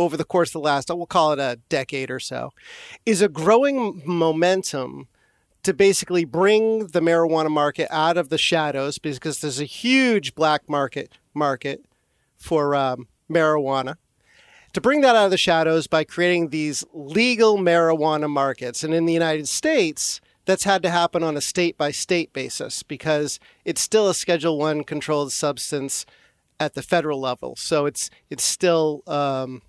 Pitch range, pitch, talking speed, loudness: 145-175 Hz, 160 Hz, 160 wpm, -21 LUFS